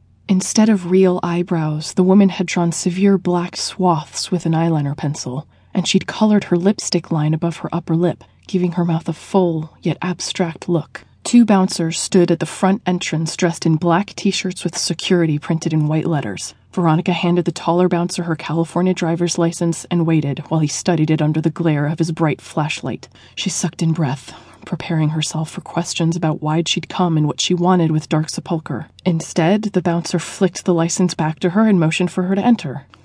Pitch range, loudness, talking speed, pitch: 160-180 Hz, -18 LUFS, 195 wpm, 170 Hz